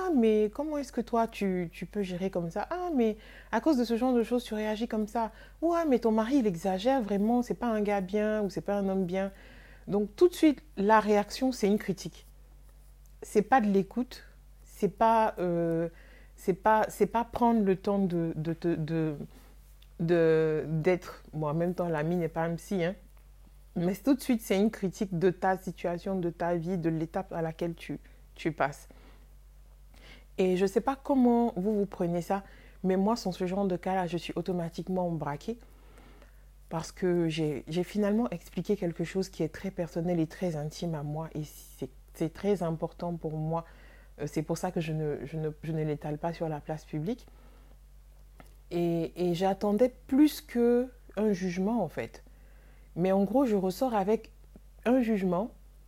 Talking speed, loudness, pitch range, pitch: 190 wpm, -30 LUFS, 170-220 Hz, 190 Hz